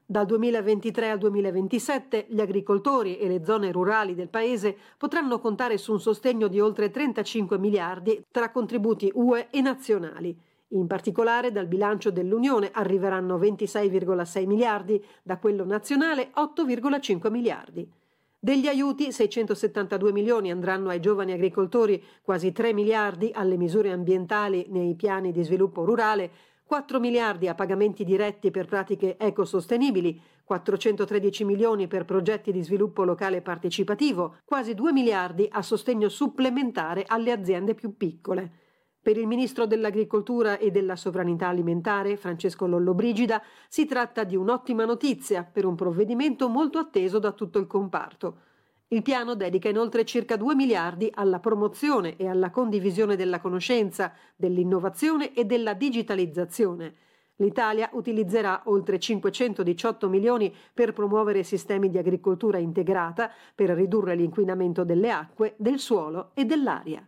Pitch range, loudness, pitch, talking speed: 190-230 Hz, -26 LUFS, 210 Hz, 130 wpm